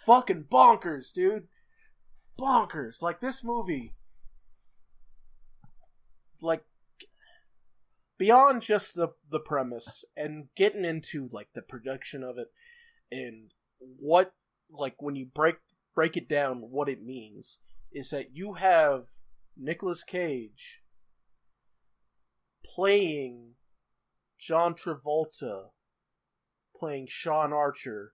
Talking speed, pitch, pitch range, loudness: 95 wpm, 160 Hz, 135-200 Hz, -28 LUFS